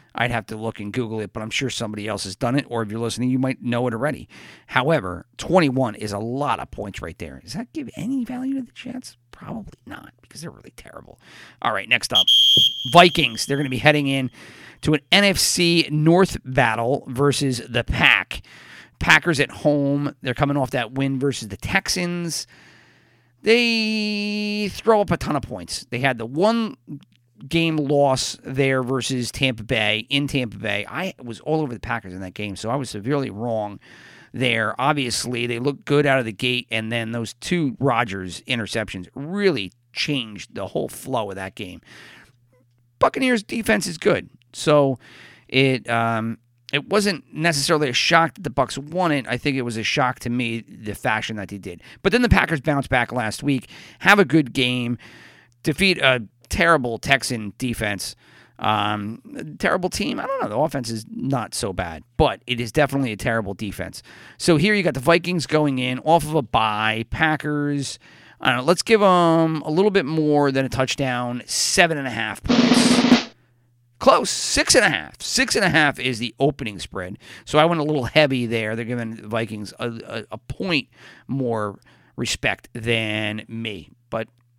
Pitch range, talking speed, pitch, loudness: 115-150 Hz, 185 wpm, 130 Hz, -21 LUFS